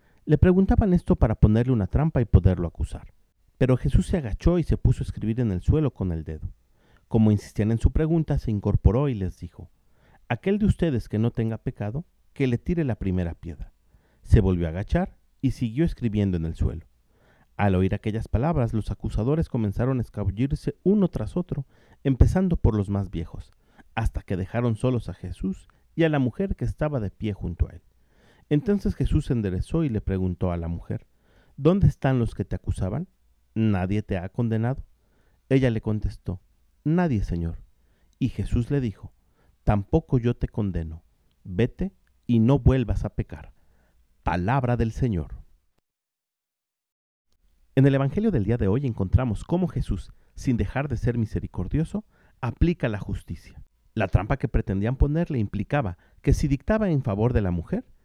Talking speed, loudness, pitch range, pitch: 170 wpm, -25 LUFS, 95-135 Hz, 110 Hz